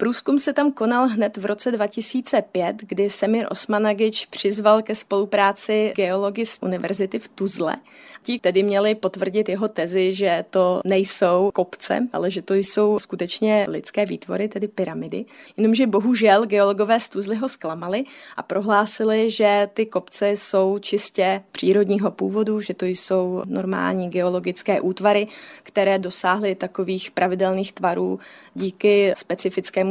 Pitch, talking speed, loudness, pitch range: 200 Hz, 135 wpm, -21 LUFS, 190-215 Hz